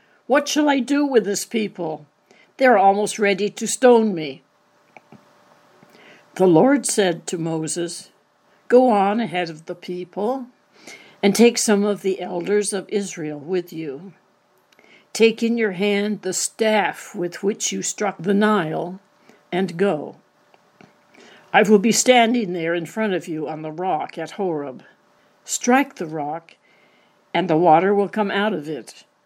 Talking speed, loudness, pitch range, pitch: 150 wpm, -20 LUFS, 180-220 Hz, 200 Hz